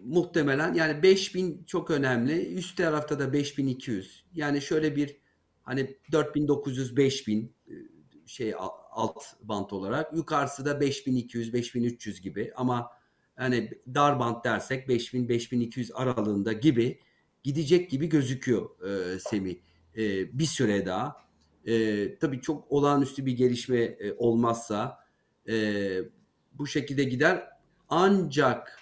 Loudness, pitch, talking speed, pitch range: -28 LUFS, 130 Hz, 100 wpm, 115-145 Hz